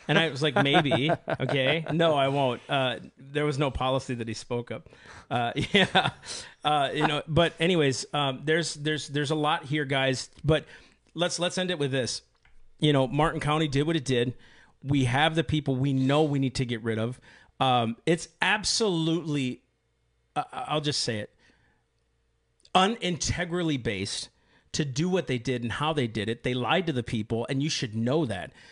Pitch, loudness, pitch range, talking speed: 140 Hz, -27 LUFS, 125-160 Hz, 190 wpm